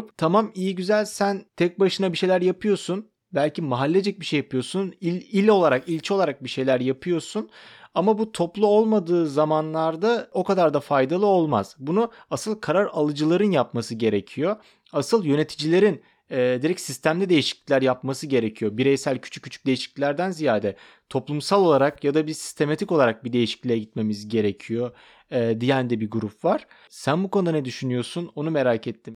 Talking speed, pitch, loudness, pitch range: 155 wpm, 155 Hz, -23 LUFS, 130-190 Hz